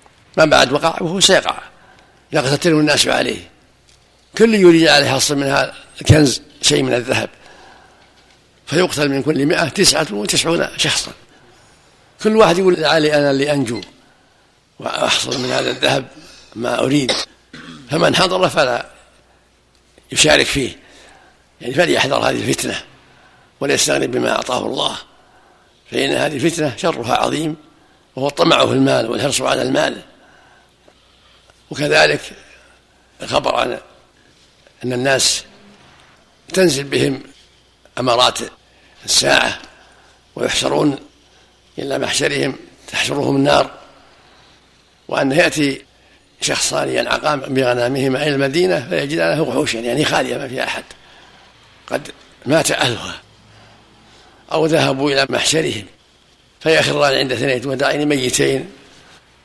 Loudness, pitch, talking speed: -16 LUFS, 135 Hz, 105 wpm